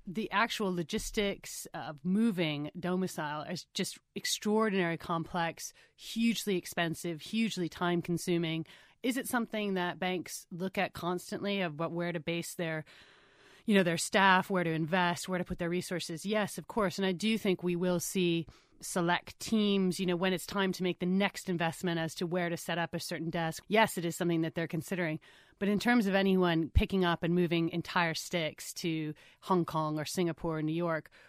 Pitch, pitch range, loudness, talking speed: 180 Hz, 165-195 Hz, -32 LUFS, 190 wpm